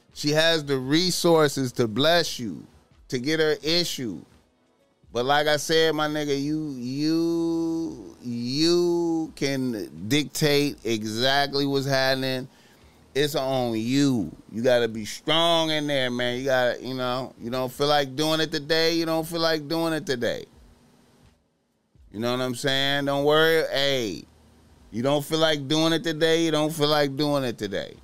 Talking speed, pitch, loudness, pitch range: 165 wpm, 145 Hz, -24 LUFS, 125-160 Hz